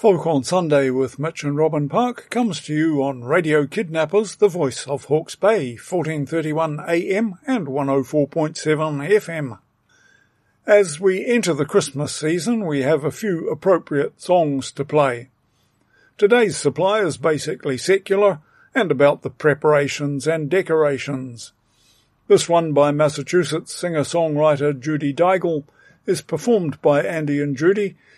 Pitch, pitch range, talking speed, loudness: 155 Hz, 140-185 Hz, 130 wpm, -20 LUFS